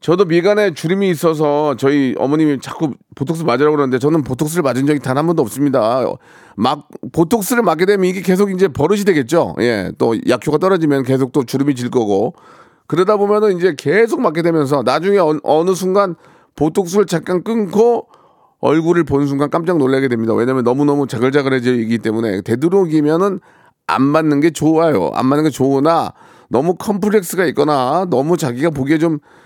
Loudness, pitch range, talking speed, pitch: -15 LUFS, 140-185 Hz, 385 characters per minute, 155 Hz